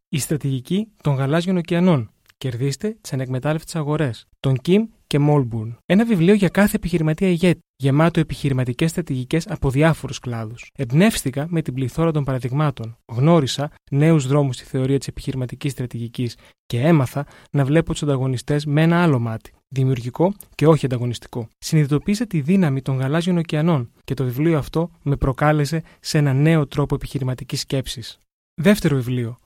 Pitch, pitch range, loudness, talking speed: 145 Hz, 130-165 Hz, -20 LUFS, 150 wpm